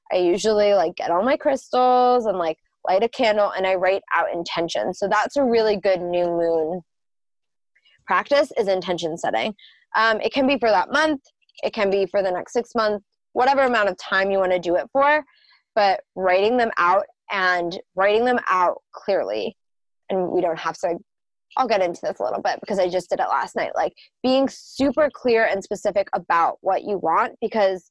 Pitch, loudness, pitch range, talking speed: 205 Hz, -21 LUFS, 185-250 Hz, 200 wpm